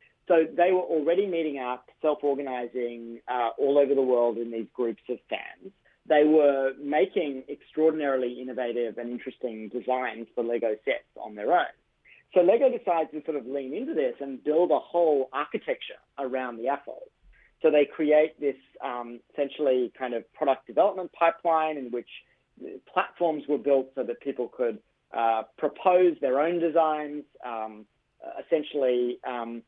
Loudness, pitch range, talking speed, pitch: -27 LUFS, 120-160 Hz, 155 wpm, 140 Hz